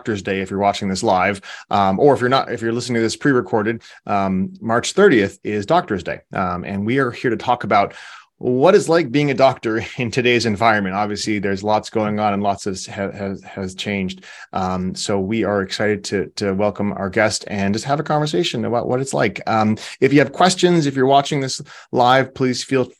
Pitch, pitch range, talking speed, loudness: 110 Hz, 100-130 Hz, 220 wpm, -18 LUFS